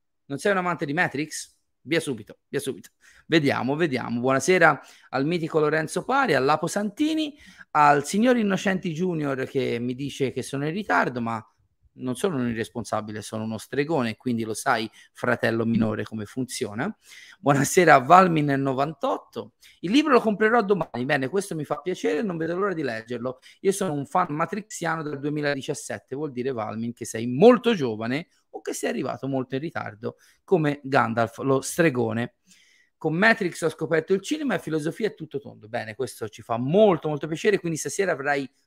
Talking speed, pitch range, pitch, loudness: 170 wpm, 125-185 Hz, 150 Hz, -24 LUFS